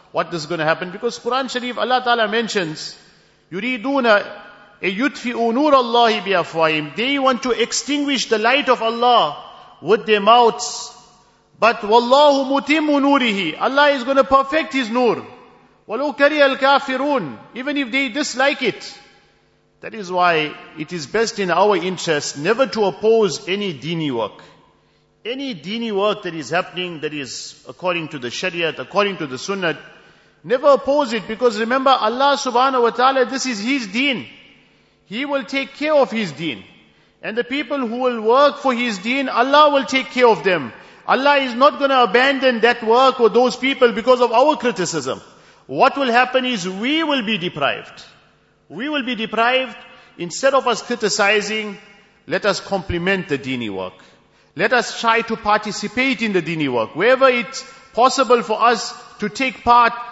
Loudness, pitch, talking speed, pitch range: -17 LUFS, 235 Hz, 160 wpm, 200-265 Hz